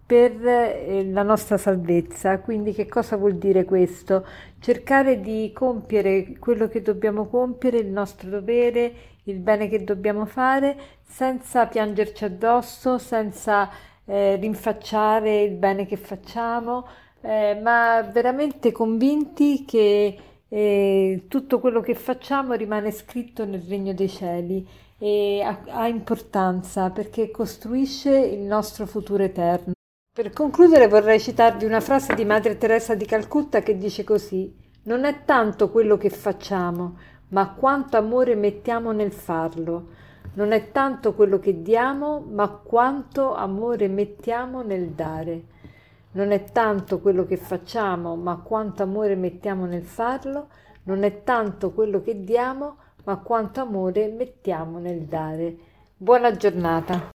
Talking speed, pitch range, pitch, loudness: 130 wpm, 195-235 Hz, 215 Hz, -22 LUFS